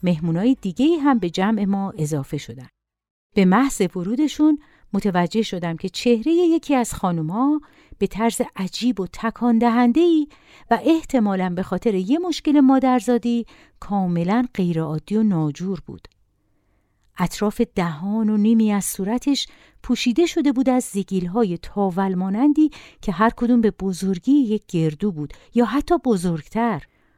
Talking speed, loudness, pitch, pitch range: 135 wpm, -20 LUFS, 215 Hz, 185-250 Hz